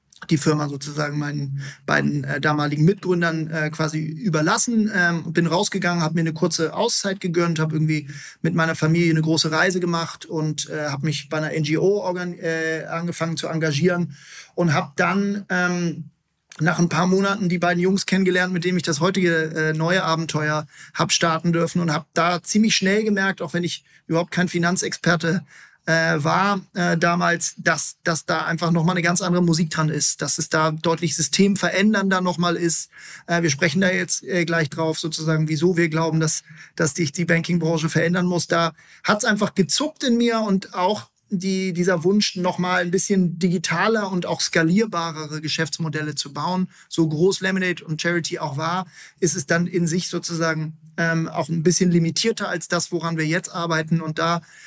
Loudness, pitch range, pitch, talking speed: -21 LUFS, 160-180 Hz, 170 Hz, 185 wpm